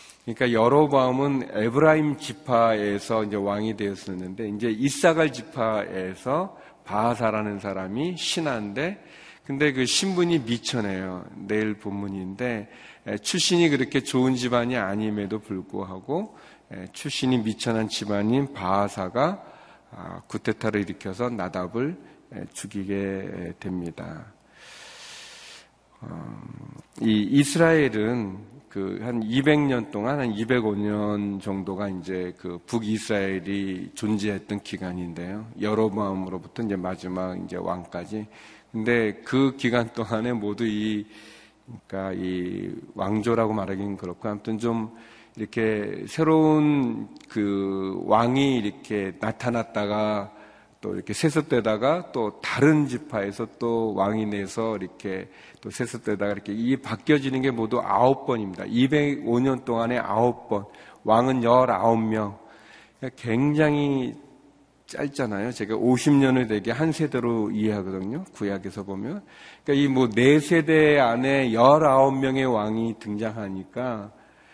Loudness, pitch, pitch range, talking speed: -25 LUFS, 110 Hz, 100-130 Hz, 260 characters per minute